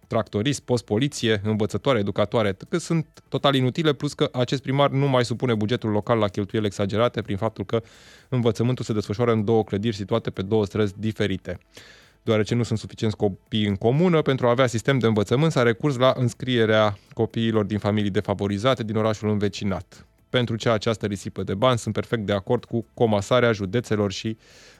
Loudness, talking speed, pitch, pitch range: -23 LUFS, 175 wpm, 115 Hz, 105-125 Hz